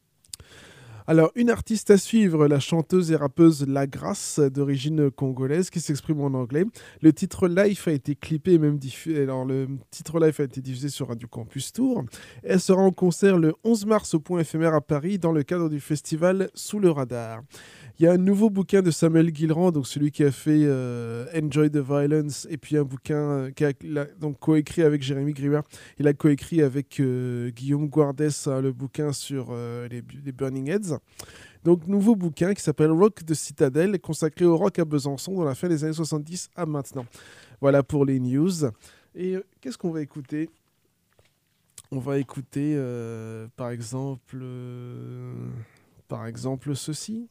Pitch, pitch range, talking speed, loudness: 150 Hz, 135-165 Hz, 180 wpm, -24 LUFS